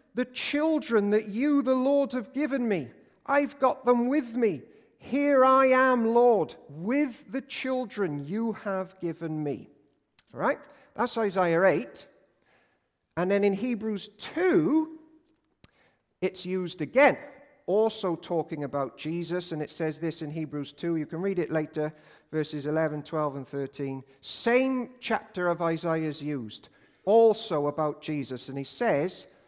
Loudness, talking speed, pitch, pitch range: -28 LUFS, 145 wpm, 195 Hz, 155-255 Hz